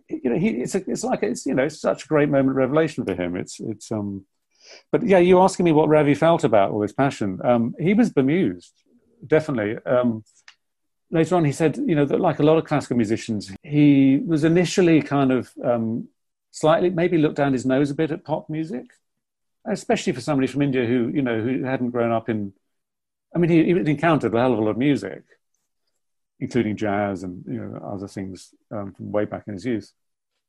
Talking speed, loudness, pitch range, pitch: 215 wpm, -21 LUFS, 110-160 Hz, 135 Hz